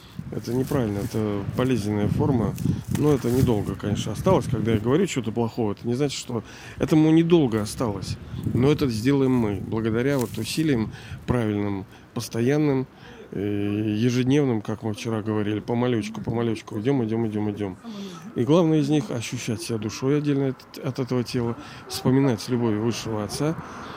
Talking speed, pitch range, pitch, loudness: 150 wpm, 110-135 Hz, 120 Hz, -24 LUFS